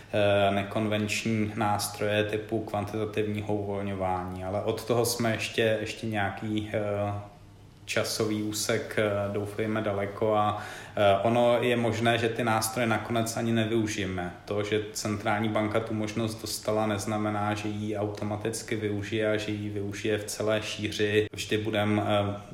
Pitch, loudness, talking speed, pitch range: 105 Hz, -28 LUFS, 120 wpm, 105-110 Hz